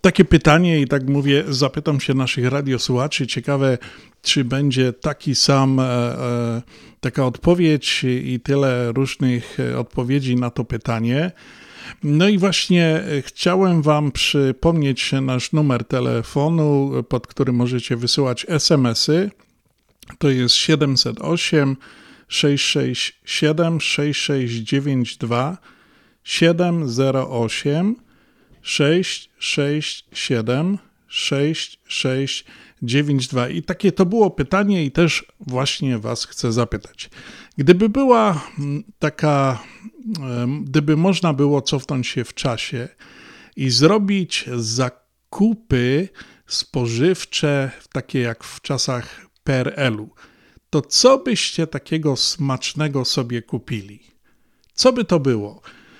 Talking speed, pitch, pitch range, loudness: 100 wpm, 140 Hz, 125-160 Hz, -19 LUFS